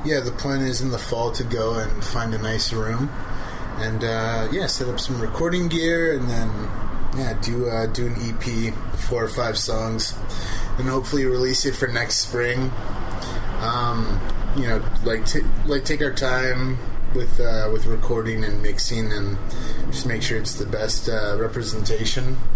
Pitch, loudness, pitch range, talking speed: 115 Hz, -24 LUFS, 110-125 Hz, 175 wpm